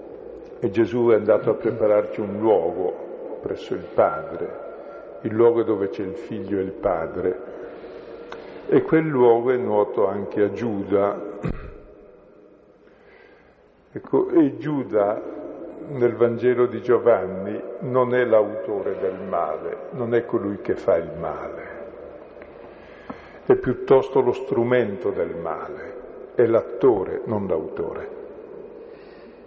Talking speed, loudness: 115 wpm, -22 LUFS